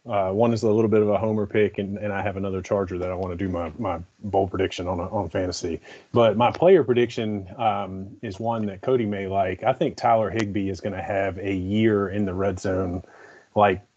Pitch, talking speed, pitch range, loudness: 100 Hz, 235 wpm, 95-110 Hz, -24 LUFS